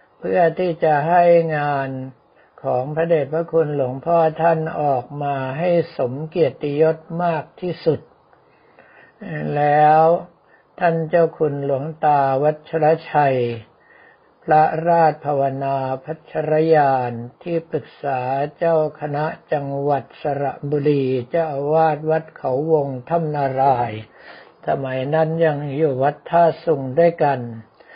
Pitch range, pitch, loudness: 135-165 Hz, 150 Hz, -19 LUFS